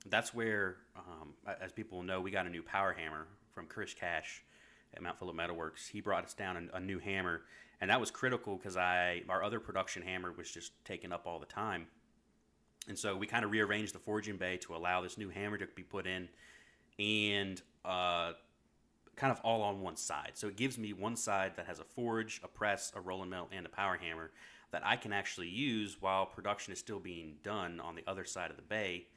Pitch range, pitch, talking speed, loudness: 90-105 Hz, 95 Hz, 220 wpm, -39 LUFS